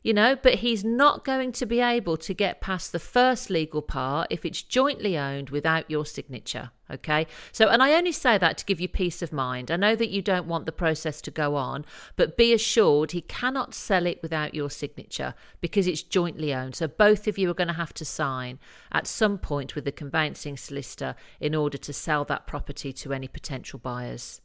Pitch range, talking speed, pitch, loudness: 145-210 Hz, 215 wpm, 160 Hz, -26 LUFS